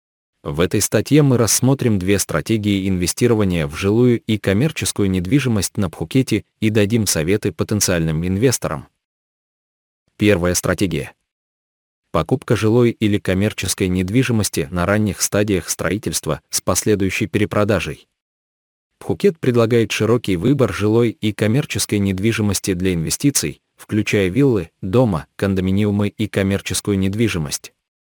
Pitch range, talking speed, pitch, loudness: 95-115 Hz, 110 wpm, 105 Hz, -18 LUFS